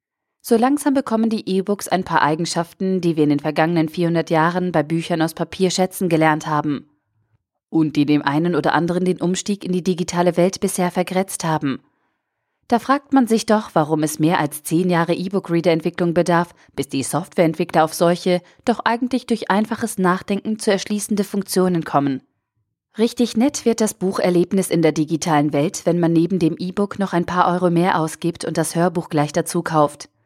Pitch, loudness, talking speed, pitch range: 175 Hz, -19 LUFS, 180 wpm, 160-195 Hz